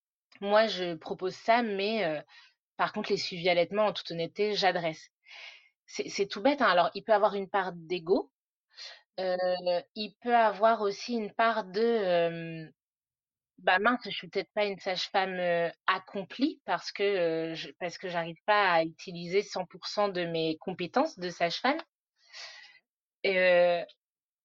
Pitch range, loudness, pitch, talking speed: 175-215 Hz, -29 LUFS, 190 Hz, 150 wpm